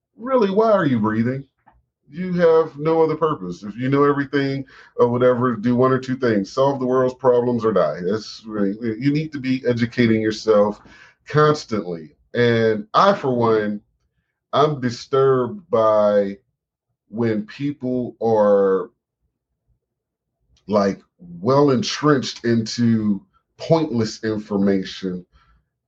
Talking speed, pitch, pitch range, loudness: 120 wpm, 120 Hz, 110-140 Hz, -19 LUFS